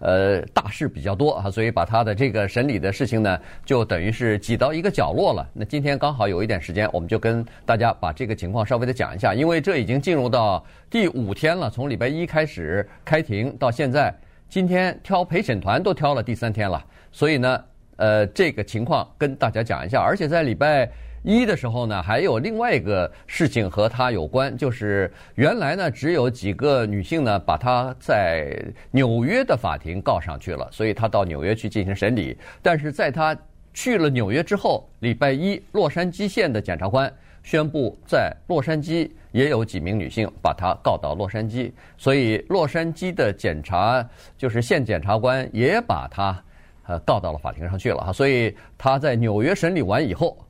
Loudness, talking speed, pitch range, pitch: -22 LUFS, 290 characters per minute, 105-145 Hz, 120 Hz